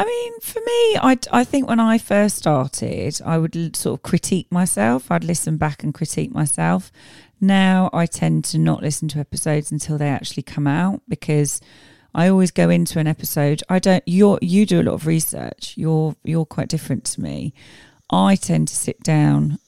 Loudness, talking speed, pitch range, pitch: -19 LUFS, 190 wpm, 150-190 Hz, 165 Hz